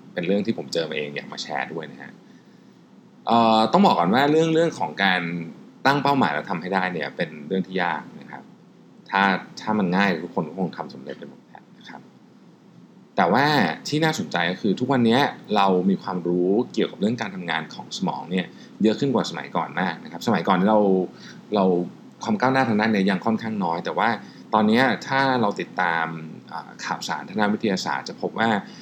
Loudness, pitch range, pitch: -22 LUFS, 90-125 Hz, 100 Hz